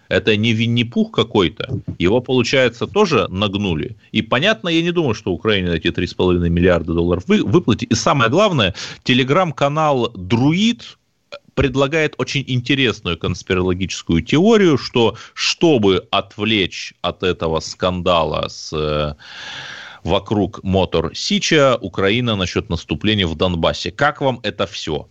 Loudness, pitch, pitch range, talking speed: -17 LUFS, 110 Hz, 90-140 Hz, 115 wpm